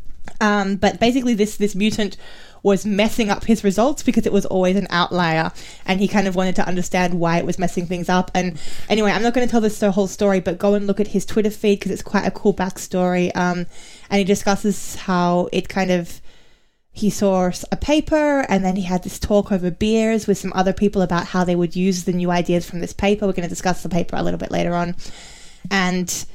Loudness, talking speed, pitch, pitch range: -20 LUFS, 230 wpm, 190 Hz, 180-205 Hz